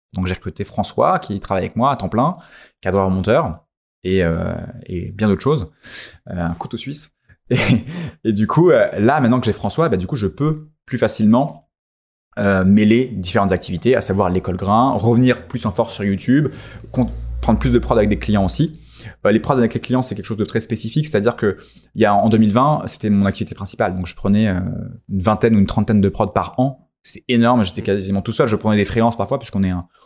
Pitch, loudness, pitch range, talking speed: 110 Hz, -18 LUFS, 95-120 Hz, 220 wpm